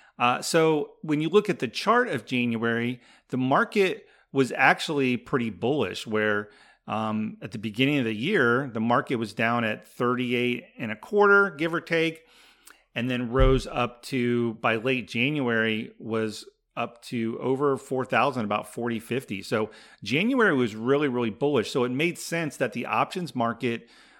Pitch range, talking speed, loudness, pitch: 115-145 Hz, 165 wpm, -26 LUFS, 125 Hz